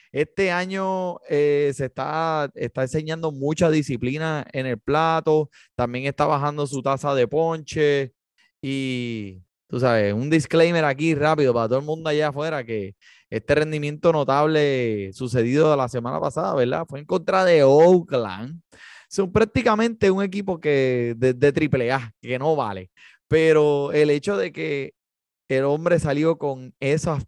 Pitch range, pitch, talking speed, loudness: 130-160 Hz, 145 Hz, 145 wpm, -22 LUFS